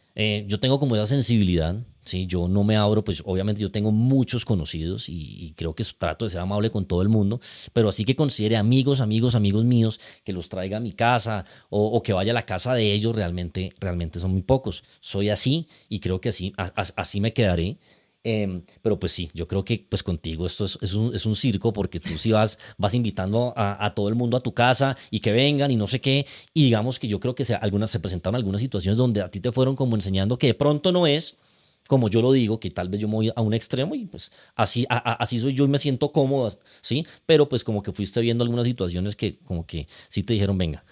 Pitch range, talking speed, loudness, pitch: 100-120 Hz, 250 wpm, -23 LUFS, 110 Hz